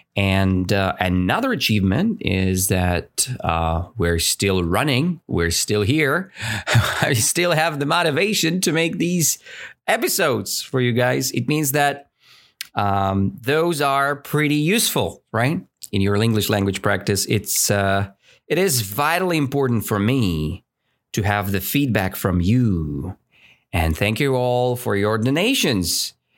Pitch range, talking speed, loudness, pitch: 95-145 Hz, 135 wpm, -20 LUFS, 110 Hz